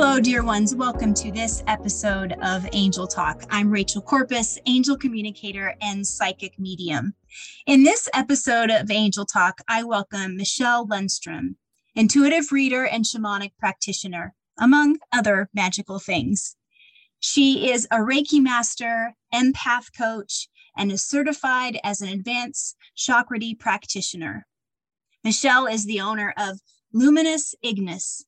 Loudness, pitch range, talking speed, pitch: -22 LUFS, 200-255 Hz, 125 wpm, 220 Hz